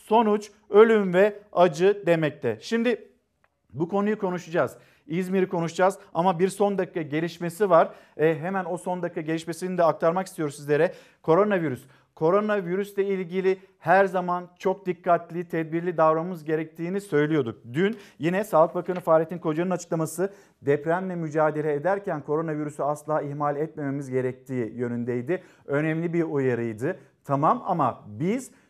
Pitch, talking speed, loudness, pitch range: 170 Hz, 125 wpm, -25 LUFS, 155-190 Hz